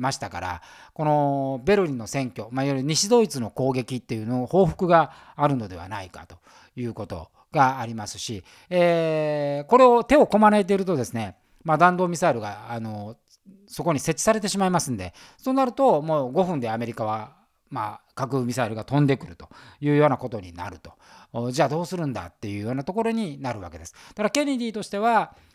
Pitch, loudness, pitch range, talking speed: 135 Hz, -23 LUFS, 115-180 Hz, 400 characters per minute